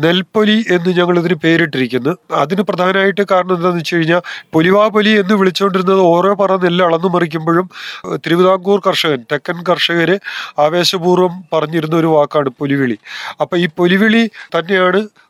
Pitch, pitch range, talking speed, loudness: 180 Hz, 165-190 Hz, 125 wpm, -13 LUFS